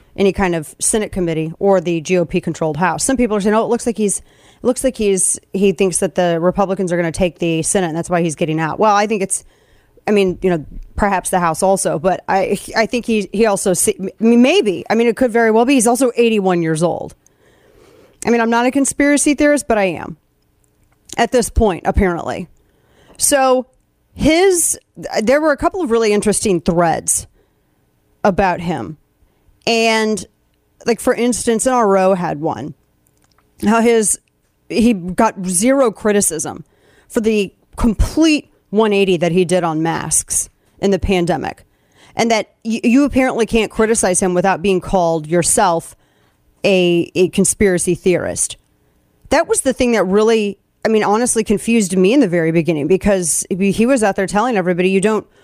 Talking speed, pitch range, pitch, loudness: 180 wpm, 180-230 Hz, 200 Hz, -15 LUFS